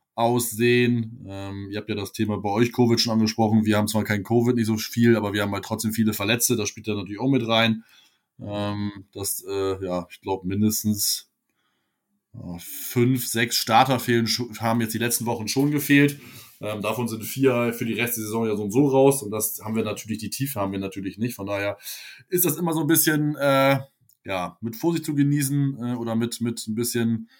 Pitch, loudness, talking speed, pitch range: 115 Hz, -23 LUFS, 215 wpm, 105-125 Hz